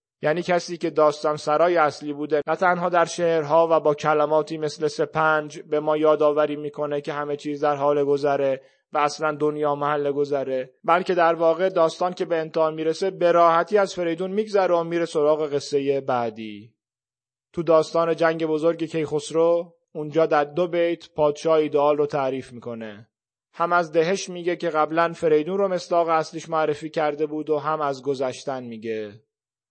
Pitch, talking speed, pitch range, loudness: 155 Hz, 165 wpm, 145-165 Hz, -22 LUFS